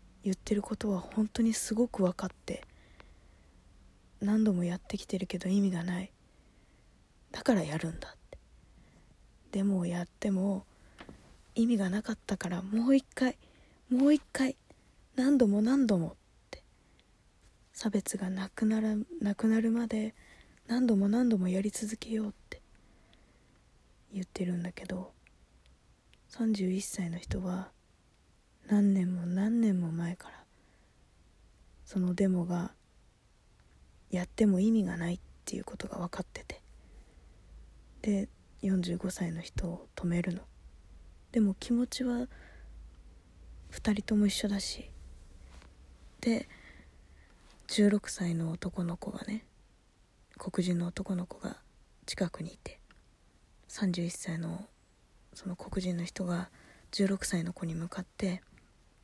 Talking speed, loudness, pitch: 210 characters per minute, -32 LUFS, 185 Hz